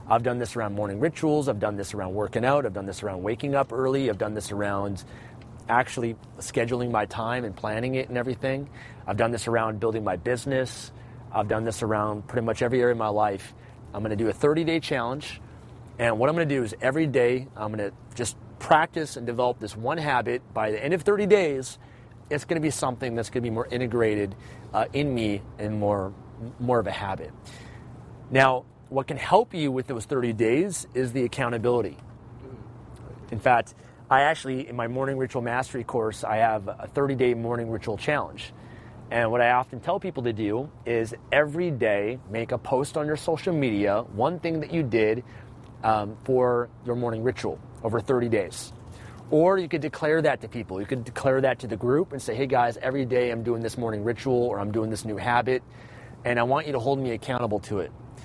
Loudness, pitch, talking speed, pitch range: -26 LUFS, 120 Hz, 210 wpm, 115-130 Hz